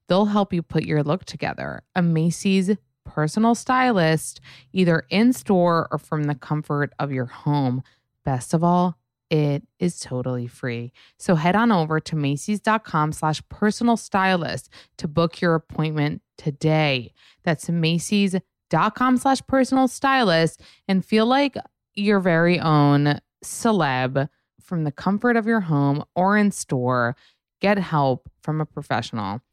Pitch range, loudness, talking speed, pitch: 145-195 Hz, -22 LUFS, 135 wpm, 160 Hz